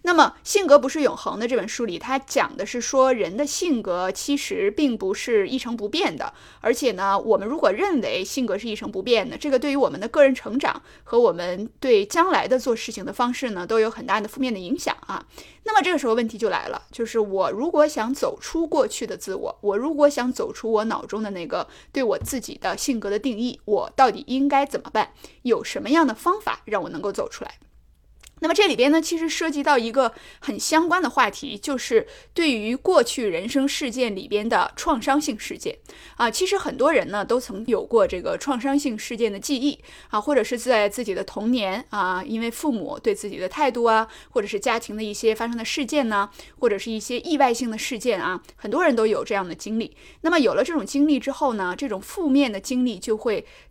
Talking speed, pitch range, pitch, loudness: 325 characters per minute, 220-295 Hz, 255 Hz, -23 LUFS